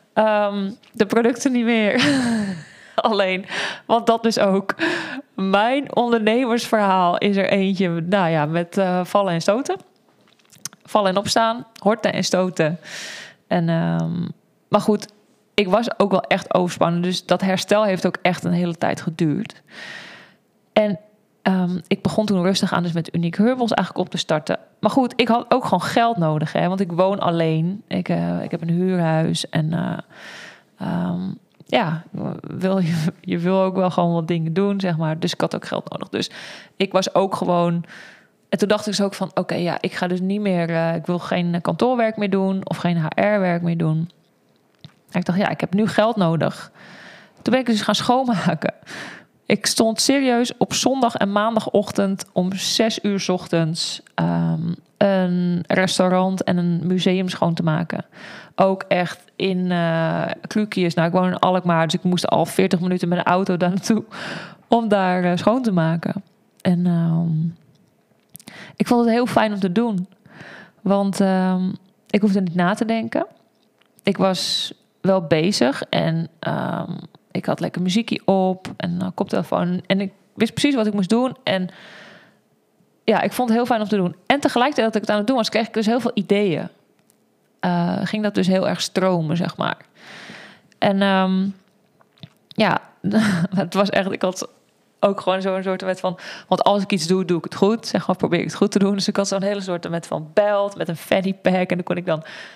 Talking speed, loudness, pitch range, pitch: 185 wpm, -20 LUFS, 175-210 Hz, 190 Hz